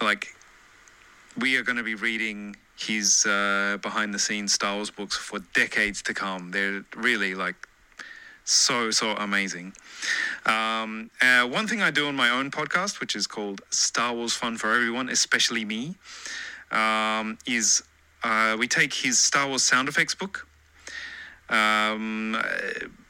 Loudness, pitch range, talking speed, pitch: -24 LUFS, 100-120 Hz, 150 wpm, 110 Hz